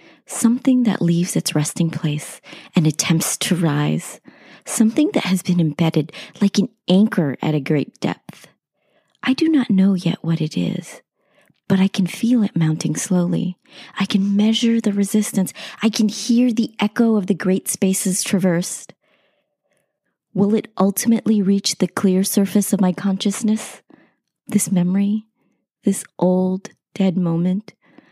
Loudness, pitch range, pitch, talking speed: -19 LUFS, 175-215 Hz, 195 Hz, 145 wpm